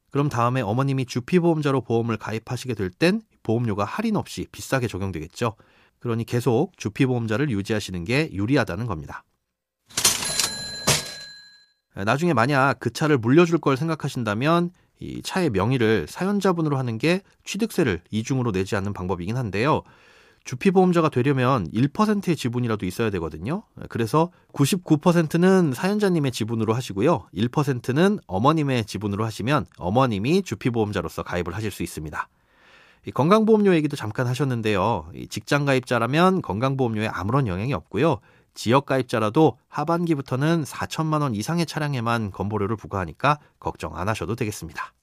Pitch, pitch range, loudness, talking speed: 130 Hz, 110-160 Hz, -23 LUFS, 360 characters per minute